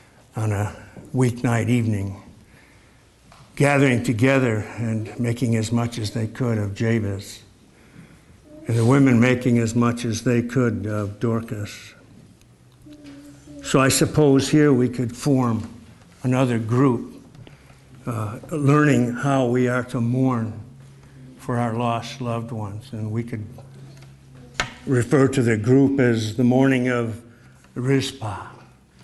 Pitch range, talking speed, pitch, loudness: 115-135 Hz, 120 wpm, 120 Hz, -21 LUFS